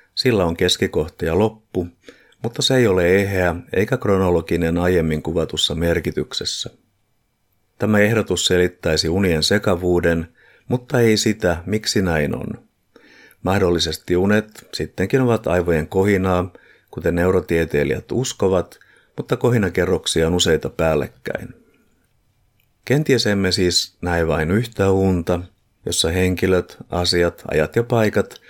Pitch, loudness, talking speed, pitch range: 95 Hz, -19 LUFS, 110 wpm, 85-105 Hz